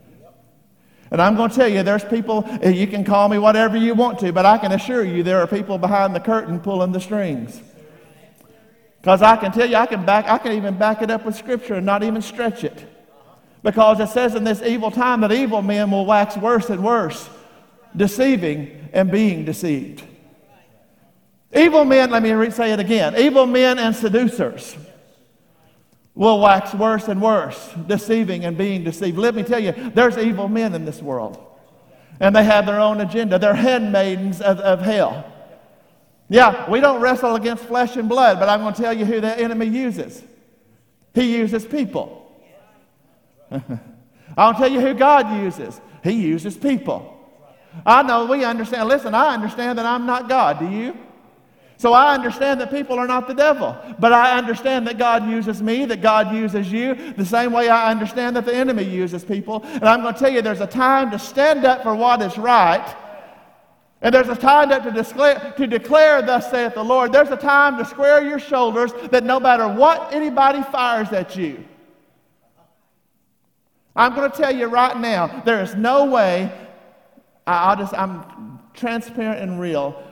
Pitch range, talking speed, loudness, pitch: 200-245 Hz, 180 wpm, -17 LUFS, 225 Hz